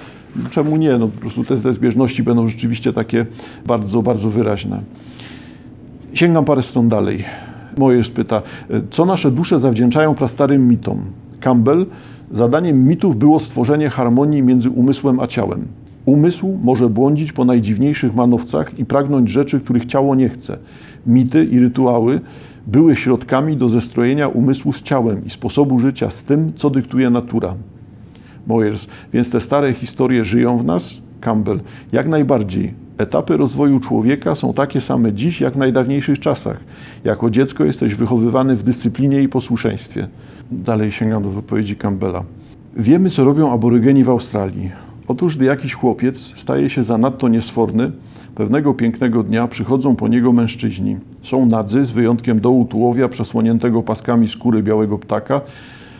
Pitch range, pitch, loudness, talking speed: 115-135 Hz, 125 Hz, -16 LUFS, 145 wpm